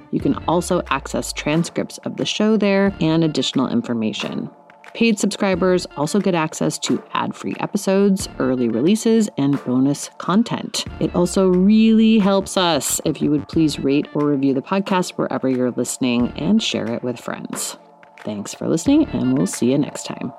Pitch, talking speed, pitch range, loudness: 170 Hz, 170 wpm, 135-200 Hz, -19 LUFS